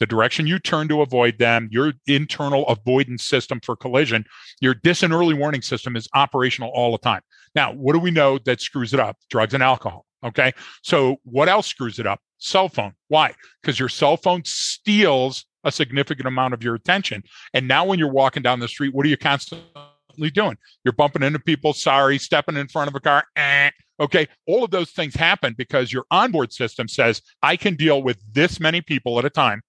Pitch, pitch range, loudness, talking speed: 140 Hz, 125-155 Hz, -20 LUFS, 210 wpm